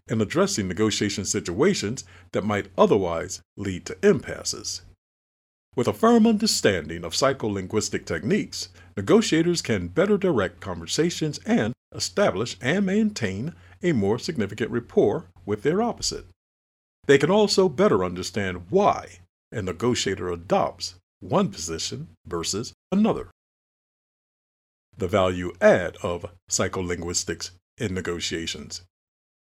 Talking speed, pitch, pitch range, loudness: 110 wpm, 95 Hz, 90-125 Hz, -24 LUFS